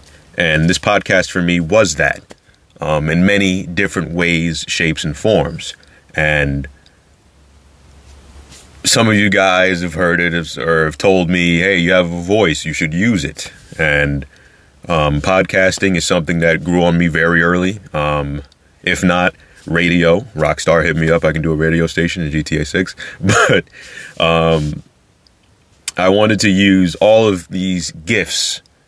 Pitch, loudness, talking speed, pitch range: 85 Hz, -14 LUFS, 155 wpm, 75-90 Hz